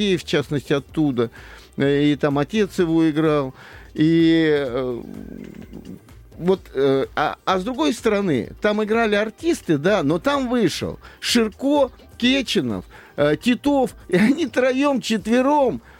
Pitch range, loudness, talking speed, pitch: 150-245 Hz, -20 LUFS, 110 wpm, 190 Hz